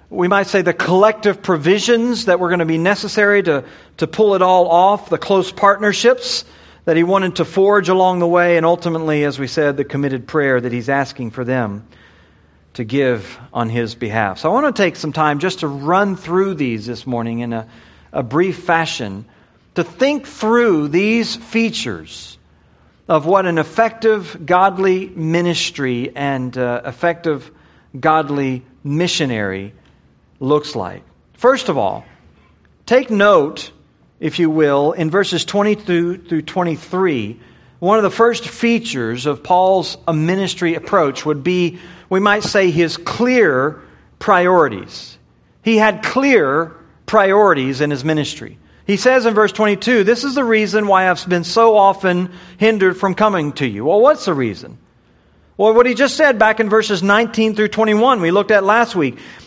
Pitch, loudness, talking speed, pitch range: 175 Hz, -15 LUFS, 165 wpm, 140-205 Hz